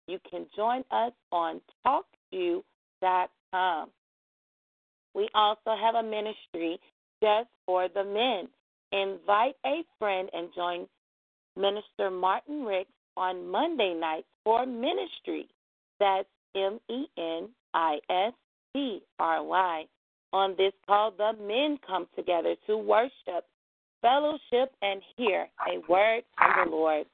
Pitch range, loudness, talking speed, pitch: 185-235 Hz, -29 LUFS, 120 wpm, 200 Hz